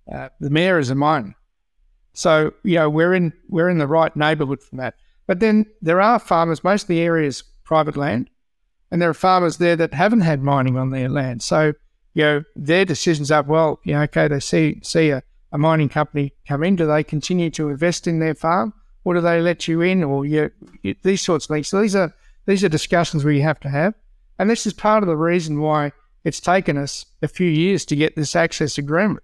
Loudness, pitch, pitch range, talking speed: -19 LUFS, 160 Hz, 150-175 Hz, 230 wpm